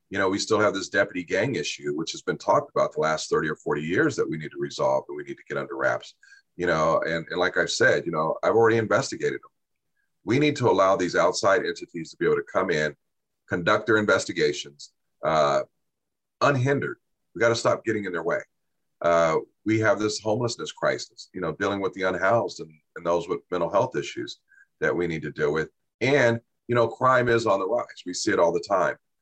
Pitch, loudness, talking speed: 120 Hz, -25 LUFS, 225 wpm